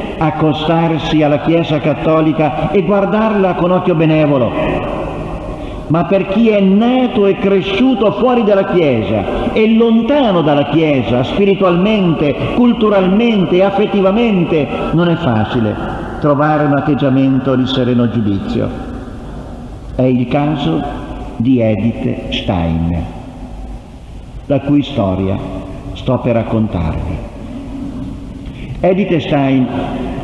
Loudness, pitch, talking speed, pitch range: -13 LUFS, 155 Hz, 95 wpm, 125-195 Hz